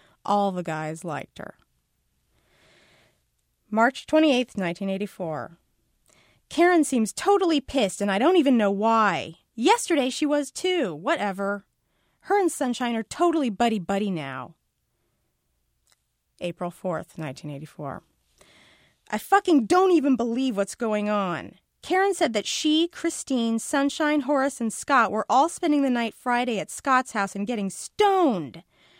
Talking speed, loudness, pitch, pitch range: 130 wpm, -24 LUFS, 230 Hz, 195-295 Hz